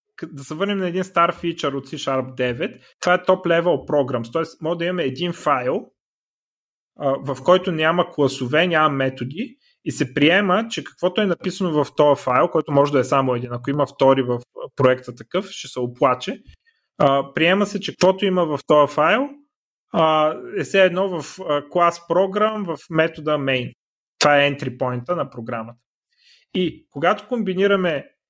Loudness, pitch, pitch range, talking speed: -20 LUFS, 160 Hz, 135-185 Hz, 165 wpm